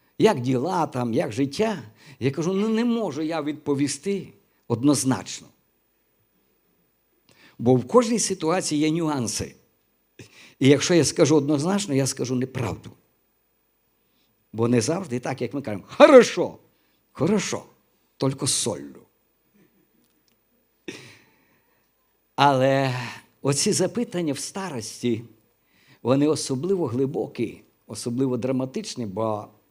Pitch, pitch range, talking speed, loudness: 135 Hz, 120-160 Hz, 100 wpm, -23 LUFS